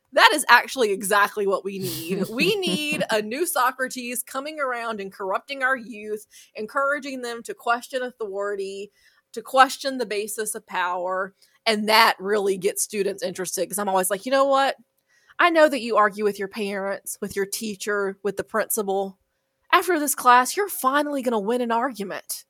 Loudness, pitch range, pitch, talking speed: -23 LUFS, 195-260 Hz, 220 Hz, 175 wpm